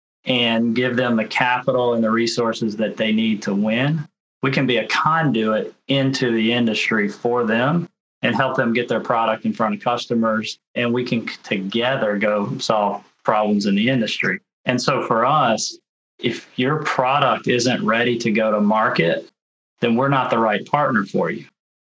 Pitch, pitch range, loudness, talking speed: 115 Hz, 110-125 Hz, -19 LUFS, 175 wpm